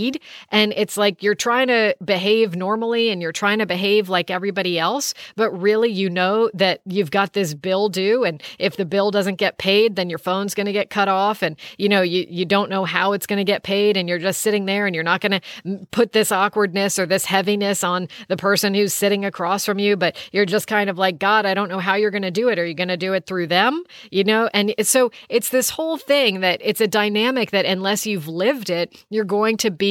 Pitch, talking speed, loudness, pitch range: 200 Hz, 245 wpm, -19 LUFS, 190-215 Hz